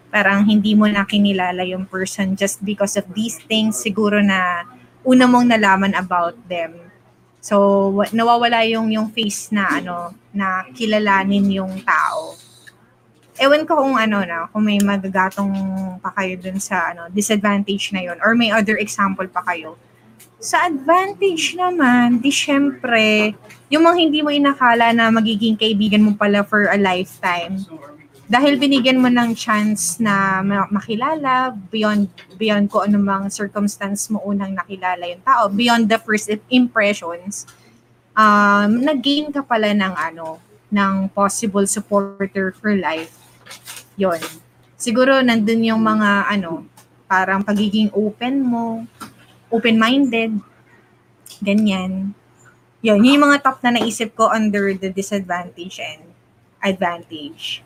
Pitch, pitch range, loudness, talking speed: 210 Hz, 195-230 Hz, -17 LUFS, 130 wpm